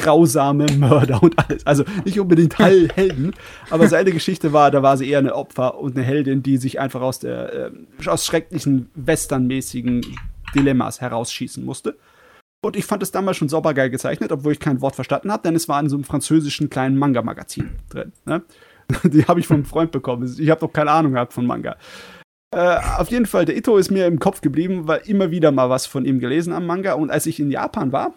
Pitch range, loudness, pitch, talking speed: 135-170 Hz, -18 LUFS, 150 Hz, 215 wpm